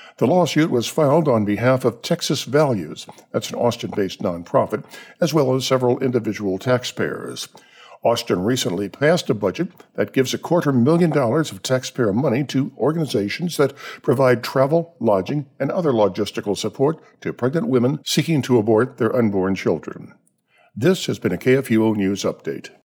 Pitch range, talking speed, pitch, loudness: 110-155 Hz, 155 wpm, 130 Hz, -20 LUFS